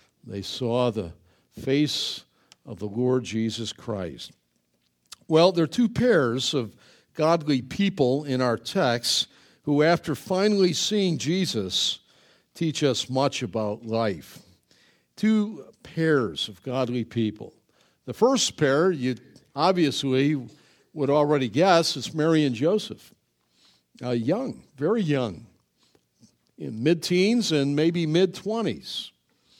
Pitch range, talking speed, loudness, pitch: 120-165 Hz, 120 wpm, -24 LUFS, 140 Hz